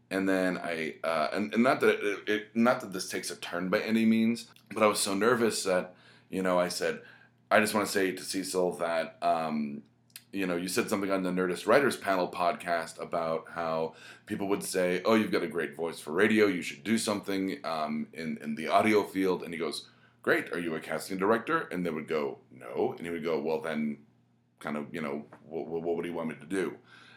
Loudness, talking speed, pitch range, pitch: -30 LUFS, 230 wpm, 85-105 Hz, 90 Hz